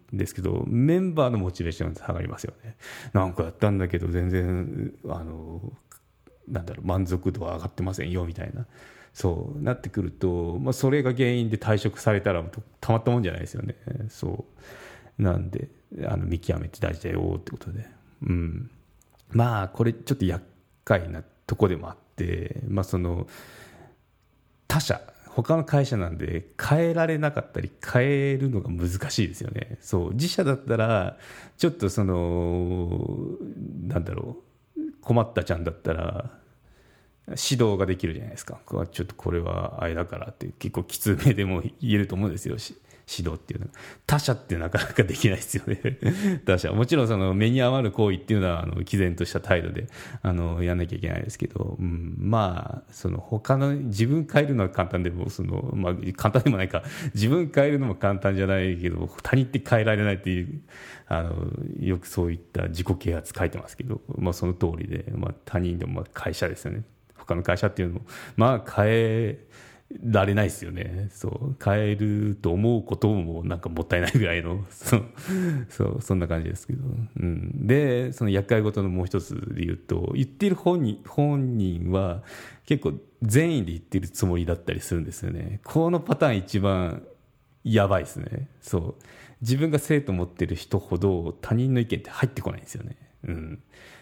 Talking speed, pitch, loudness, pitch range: 370 characters per minute, 105 Hz, -26 LUFS, 90-125 Hz